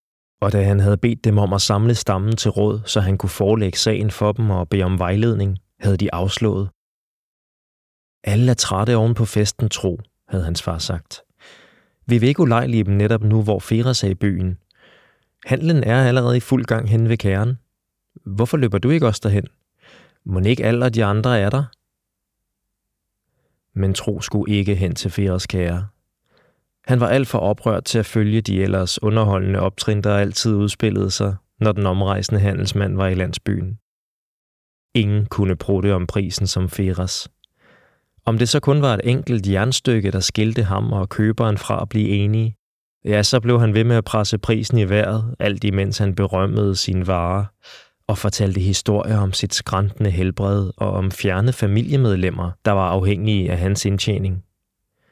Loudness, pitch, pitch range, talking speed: -19 LUFS, 105 Hz, 95-115 Hz, 175 wpm